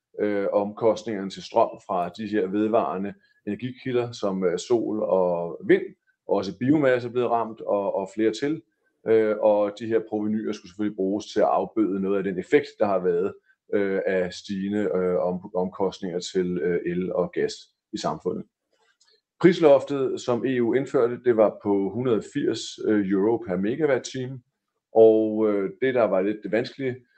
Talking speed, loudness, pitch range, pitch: 145 wpm, -24 LUFS, 100-130 Hz, 110 Hz